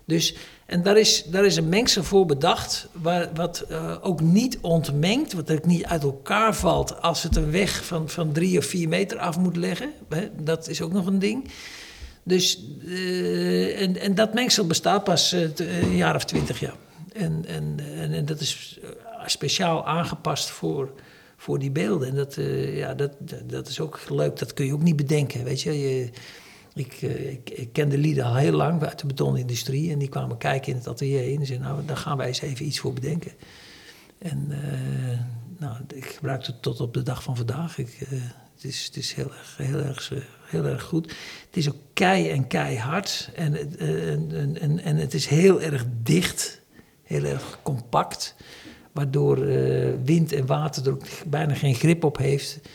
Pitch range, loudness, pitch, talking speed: 135-170 Hz, -24 LUFS, 150 Hz, 195 wpm